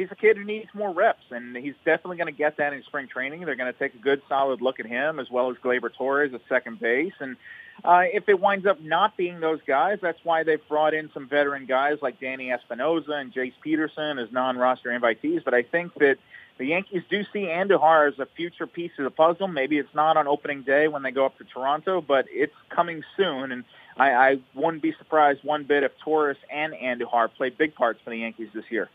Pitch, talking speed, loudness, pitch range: 150 Hz, 235 wpm, -24 LUFS, 130-170 Hz